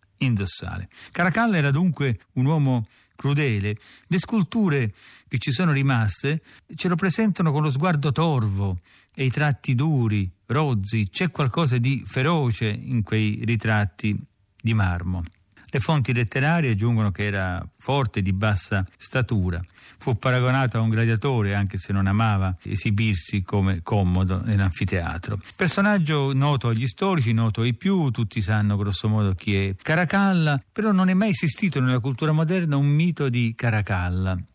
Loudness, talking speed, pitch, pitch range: -23 LUFS, 145 wpm, 120 Hz, 100-150 Hz